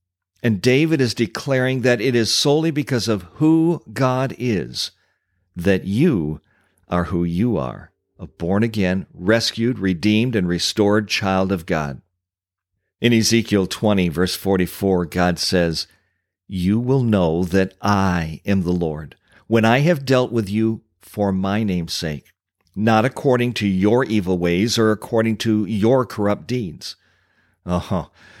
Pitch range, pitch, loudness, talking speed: 90-115 Hz, 100 Hz, -19 LUFS, 145 wpm